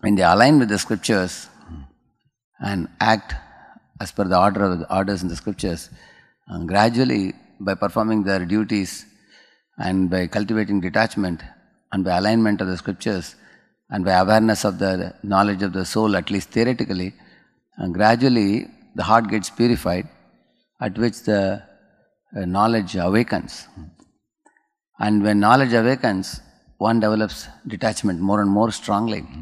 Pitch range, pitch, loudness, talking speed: 95-110 Hz, 100 Hz, -20 LUFS, 140 wpm